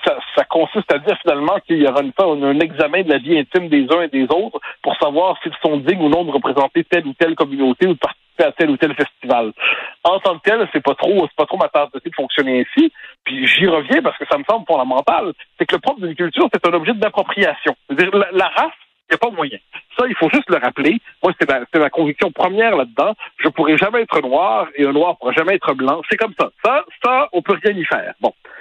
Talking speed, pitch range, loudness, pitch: 265 wpm, 145-190 Hz, -16 LUFS, 165 Hz